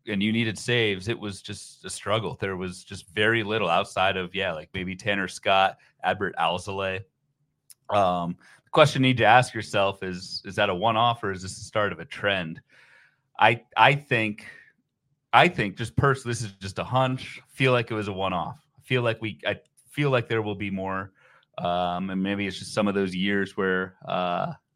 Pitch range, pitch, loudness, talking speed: 95-115 Hz, 105 Hz, -25 LUFS, 210 wpm